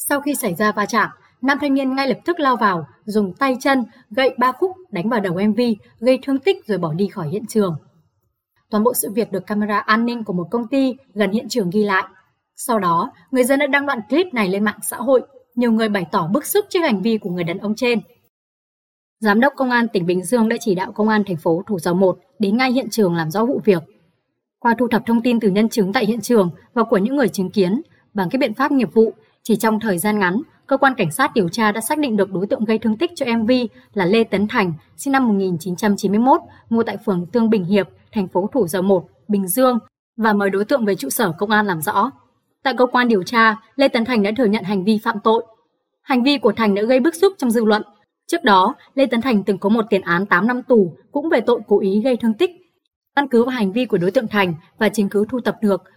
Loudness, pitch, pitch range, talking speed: -18 LUFS, 220 Hz, 200-255 Hz, 255 wpm